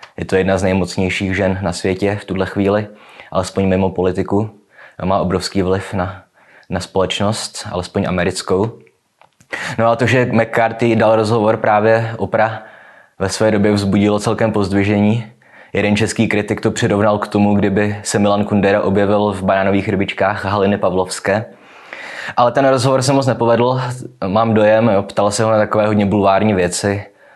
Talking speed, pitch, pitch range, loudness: 160 wpm, 105 Hz, 95-110 Hz, -16 LUFS